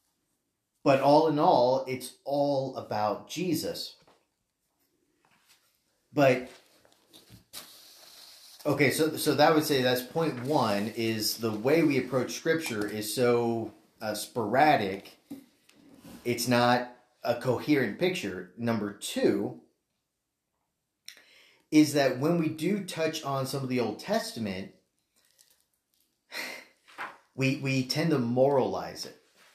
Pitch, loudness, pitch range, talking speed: 130 Hz, -28 LUFS, 120-150 Hz, 110 wpm